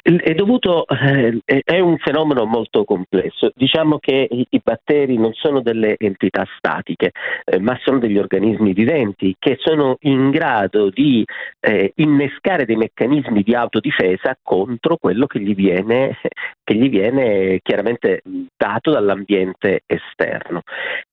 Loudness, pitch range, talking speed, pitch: -17 LUFS, 110-160 Hz, 135 wpm, 135 Hz